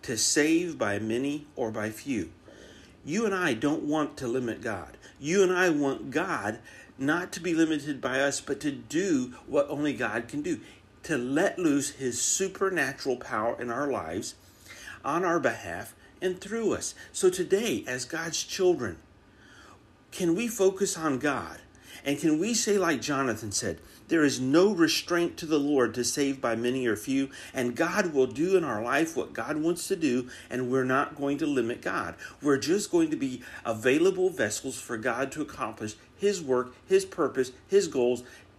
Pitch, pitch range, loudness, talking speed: 145 Hz, 125-185 Hz, -28 LUFS, 180 wpm